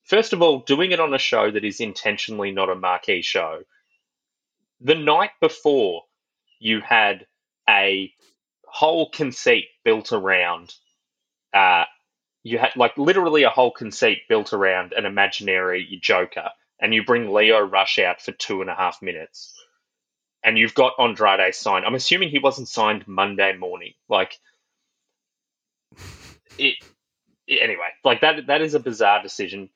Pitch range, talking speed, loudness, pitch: 100-155 Hz, 145 wpm, -19 LUFS, 125 Hz